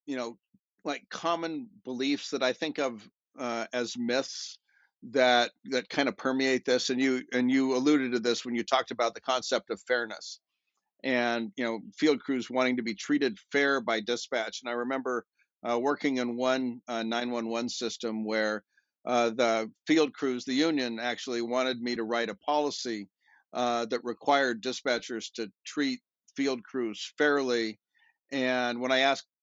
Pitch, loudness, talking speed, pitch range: 125 Hz, -30 LUFS, 165 wpm, 120-135 Hz